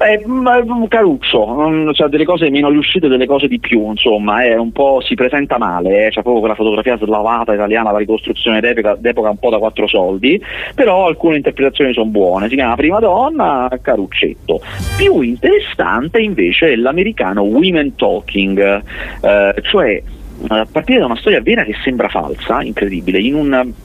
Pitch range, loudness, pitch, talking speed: 110-155 Hz, -13 LUFS, 125 Hz, 170 wpm